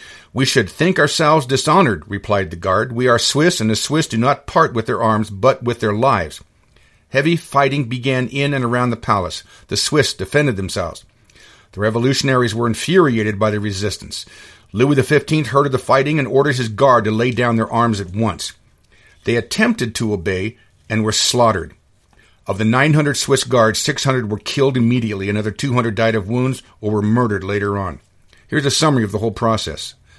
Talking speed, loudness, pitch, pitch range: 195 wpm, -17 LUFS, 120 Hz, 110-135 Hz